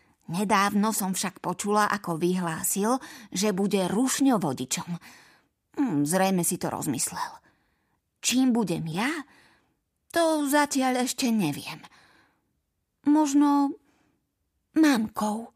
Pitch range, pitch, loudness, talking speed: 180-275 Hz, 210 Hz, -26 LUFS, 90 wpm